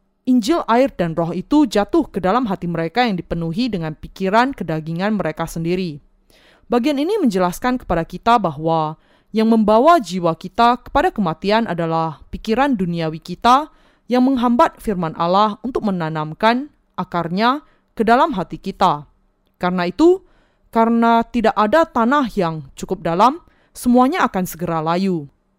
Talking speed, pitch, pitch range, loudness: 135 wpm, 205 Hz, 170-245 Hz, -18 LUFS